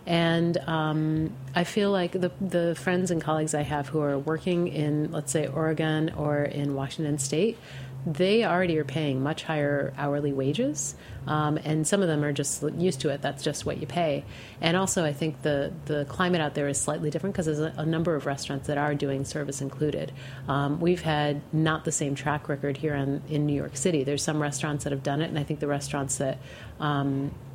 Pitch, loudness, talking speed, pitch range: 150 Hz, -27 LUFS, 215 wpm, 140-160 Hz